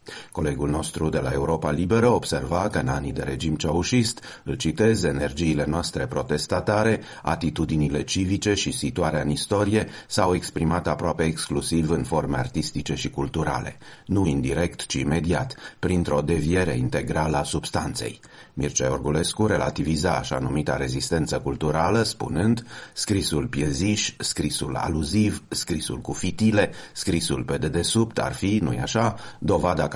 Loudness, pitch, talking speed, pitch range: -24 LUFS, 80 Hz, 130 wpm, 75-100 Hz